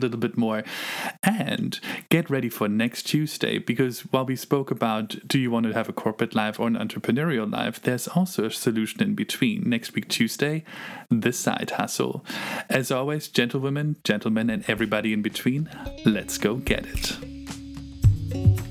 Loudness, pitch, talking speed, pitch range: -25 LUFS, 125 Hz, 165 wpm, 110-150 Hz